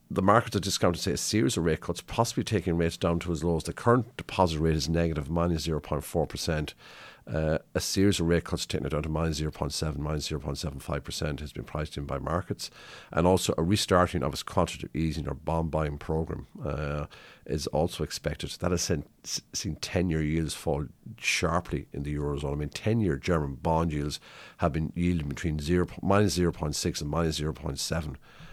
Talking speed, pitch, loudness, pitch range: 200 wpm, 80 Hz, -29 LUFS, 75-90 Hz